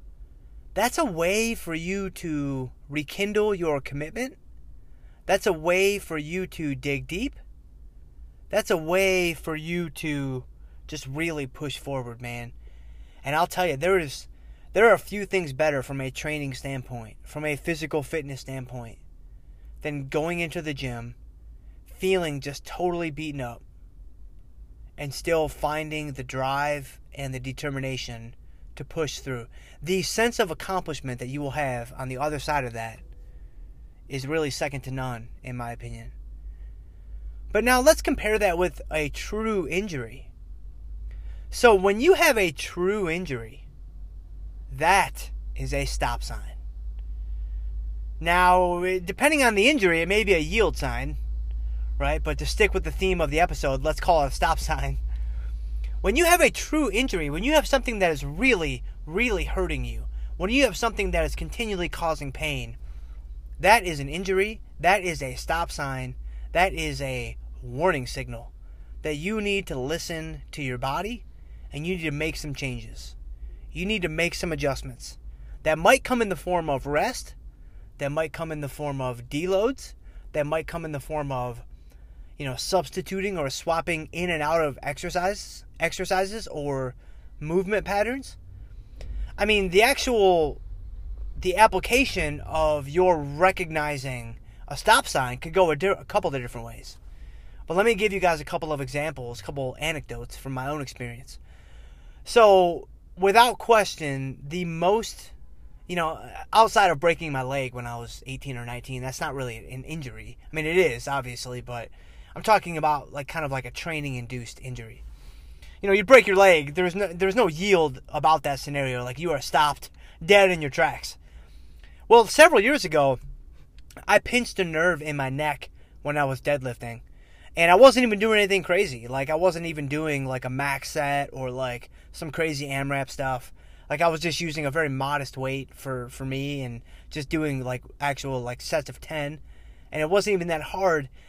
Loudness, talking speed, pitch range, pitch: -25 LUFS, 170 wpm, 120-175 Hz, 145 Hz